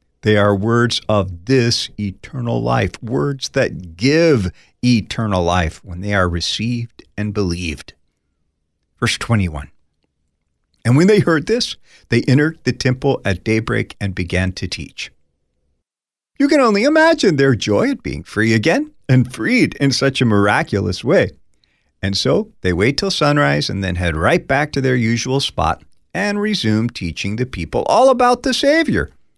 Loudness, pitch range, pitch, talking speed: -17 LUFS, 85-135 Hz, 110 Hz, 155 wpm